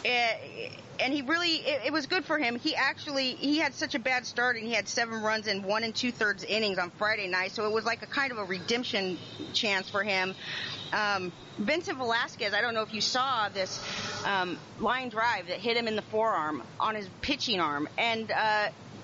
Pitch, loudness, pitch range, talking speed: 220 Hz, -29 LUFS, 200-255 Hz, 210 wpm